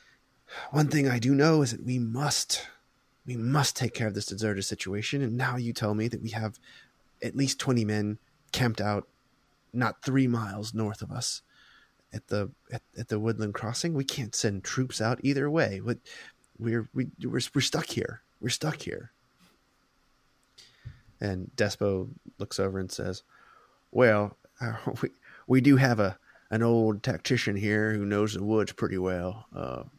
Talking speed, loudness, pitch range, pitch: 170 wpm, -29 LUFS, 105-130 Hz, 115 Hz